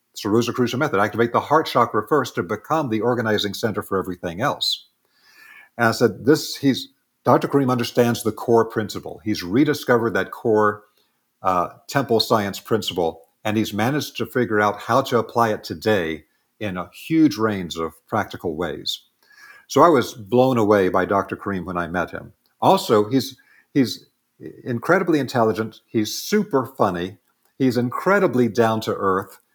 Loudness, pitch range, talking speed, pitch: -21 LUFS, 105-130 Hz, 155 wpm, 115 Hz